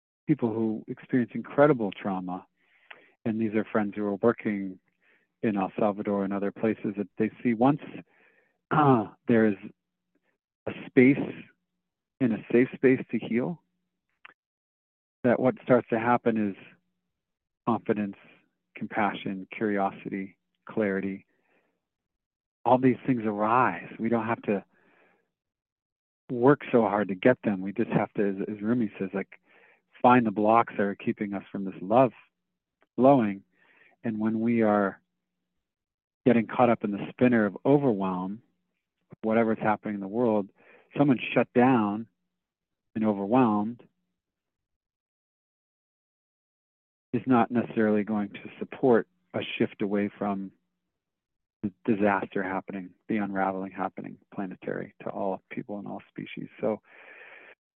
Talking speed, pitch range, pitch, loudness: 130 wpm, 100-120 Hz, 110 Hz, -27 LUFS